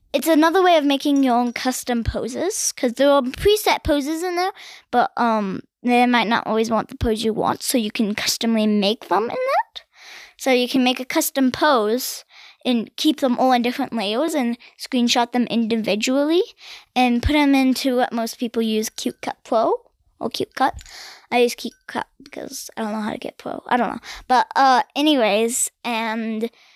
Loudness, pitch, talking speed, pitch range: -20 LUFS, 250 Hz, 195 wpm, 230-290 Hz